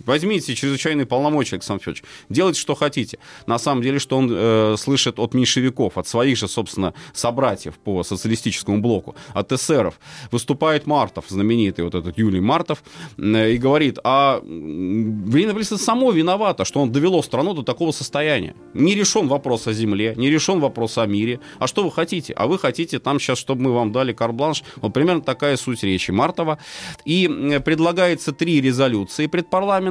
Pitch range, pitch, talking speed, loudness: 115-150 Hz, 130 Hz, 170 wpm, -20 LUFS